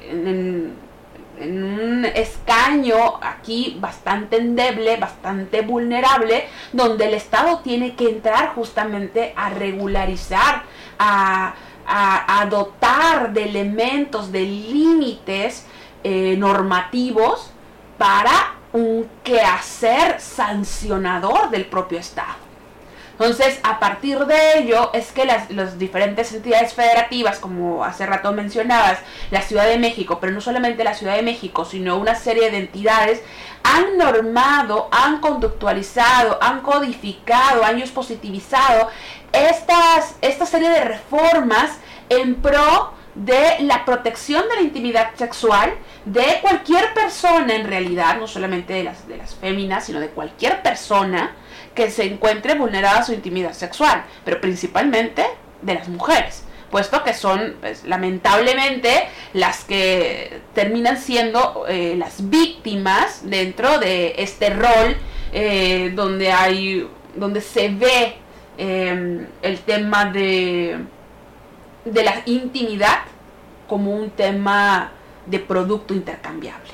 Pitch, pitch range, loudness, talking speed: 225 Hz, 195-250 Hz, -18 LUFS, 120 wpm